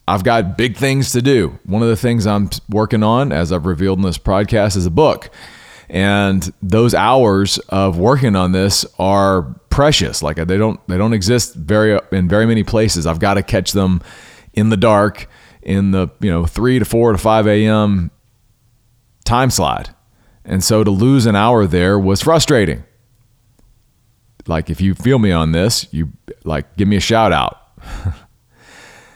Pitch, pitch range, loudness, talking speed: 105 Hz, 95-115 Hz, -14 LUFS, 175 wpm